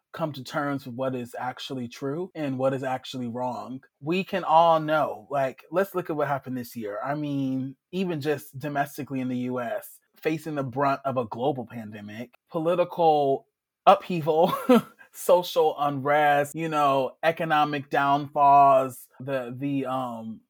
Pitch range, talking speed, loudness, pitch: 130-160 Hz, 150 wpm, -25 LUFS, 140 Hz